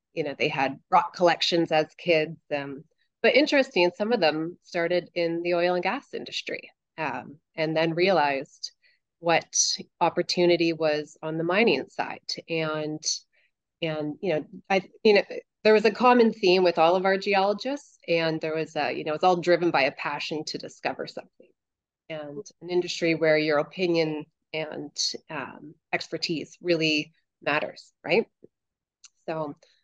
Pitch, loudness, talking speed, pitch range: 170 Hz, -25 LUFS, 155 wpm, 155-185 Hz